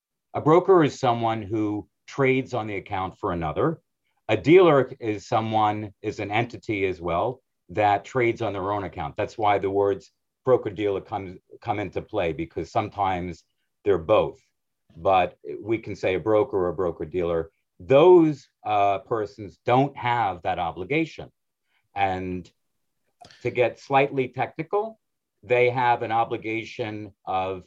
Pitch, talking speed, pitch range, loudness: 110 Hz, 145 wpm, 100-130 Hz, -24 LUFS